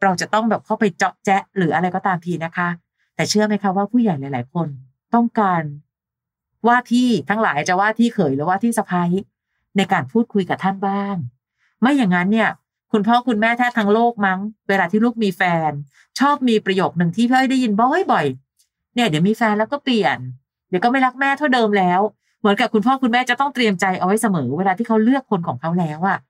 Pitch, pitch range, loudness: 200 Hz, 180-235 Hz, -18 LUFS